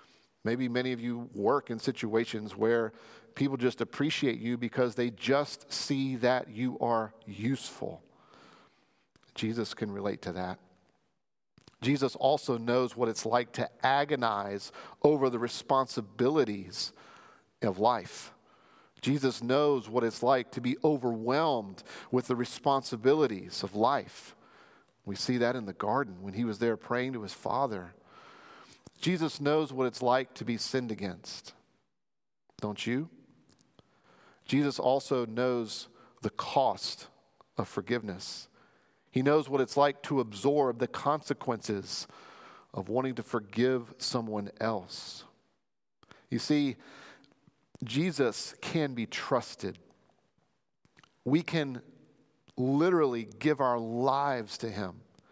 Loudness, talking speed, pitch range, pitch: -31 LUFS, 120 wpm, 115-135 Hz, 125 Hz